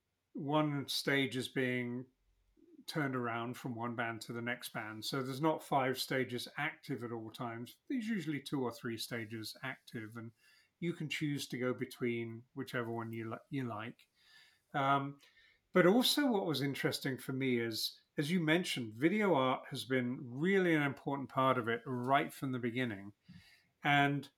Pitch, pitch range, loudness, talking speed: 130 Hz, 120-145 Hz, -36 LUFS, 170 wpm